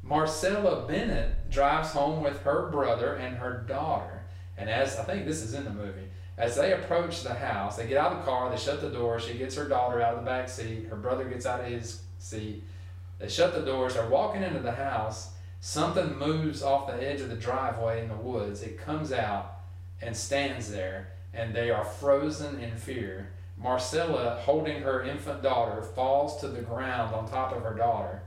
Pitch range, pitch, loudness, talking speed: 100-135 Hz, 115 Hz, -30 LUFS, 205 wpm